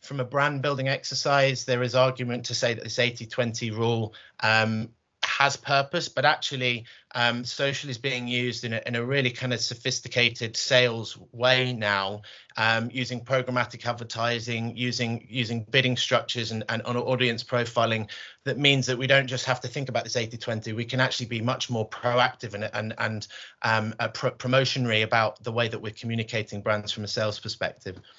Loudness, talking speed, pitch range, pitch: -26 LUFS, 180 wpm, 115-130 Hz, 120 Hz